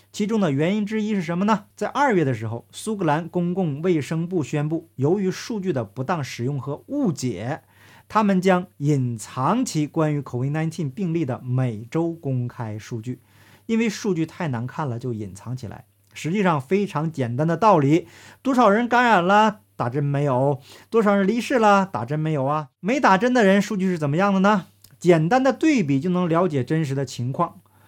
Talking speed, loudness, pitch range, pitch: 285 characters per minute, -22 LUFS, 130-195 Hz, 160 Hz